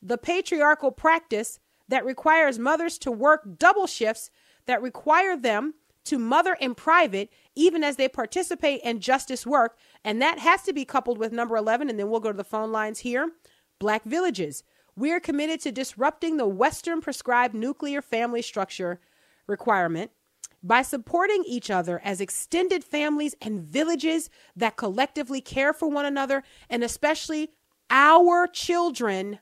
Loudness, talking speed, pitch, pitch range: -24 LUFS, 155 wpm, 270 Hz, 230-315 Hz